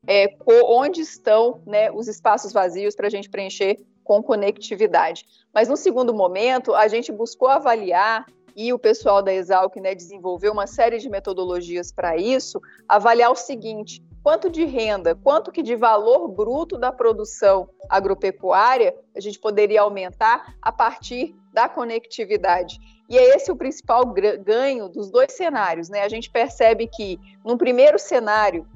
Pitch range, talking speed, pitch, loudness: 195-250 Hz, 155 wpm, 220 Hz, -19 LUFS